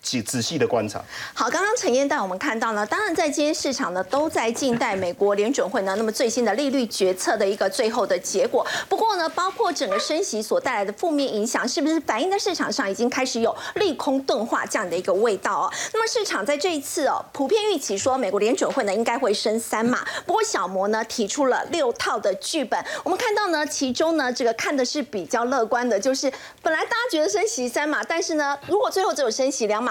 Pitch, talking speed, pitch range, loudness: 275 Hz, 360 characters per minute, 225-335 Hz, -23 LUFS